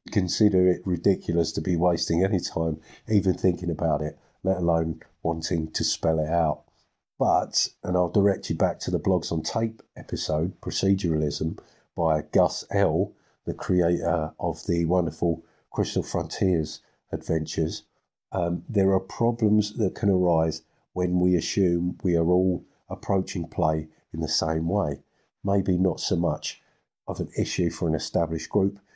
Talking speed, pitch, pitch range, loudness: 150 wpm, 85 Hz, 80-95 Hz, -26 LUFS